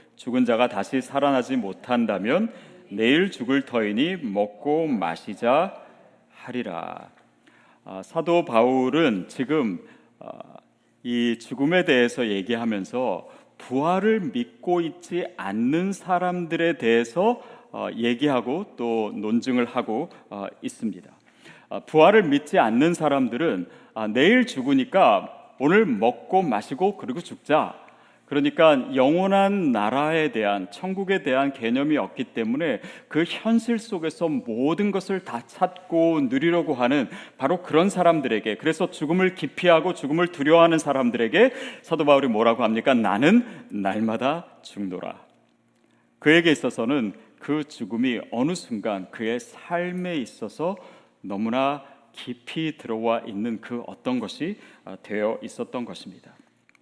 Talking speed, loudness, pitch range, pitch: 270 characters per minute, -23 LUFS, 120-190 Hz, 160 Hz